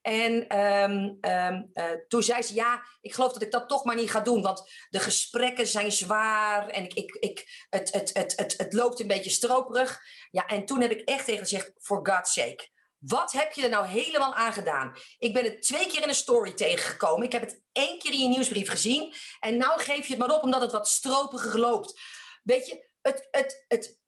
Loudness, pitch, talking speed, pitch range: -27 LUFS, 240 Hz, 230 wpm, 210-275 Hz